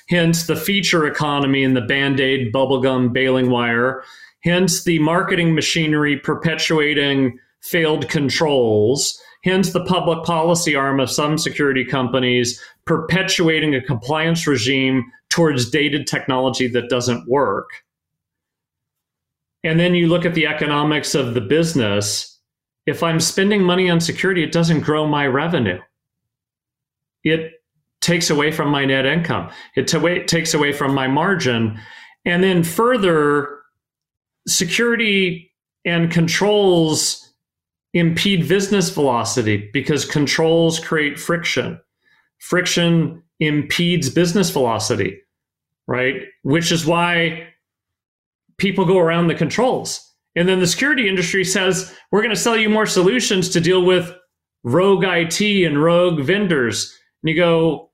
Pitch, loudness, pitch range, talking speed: 160 Hz, -17 LUFS, 140-175 Hz, 125 wpm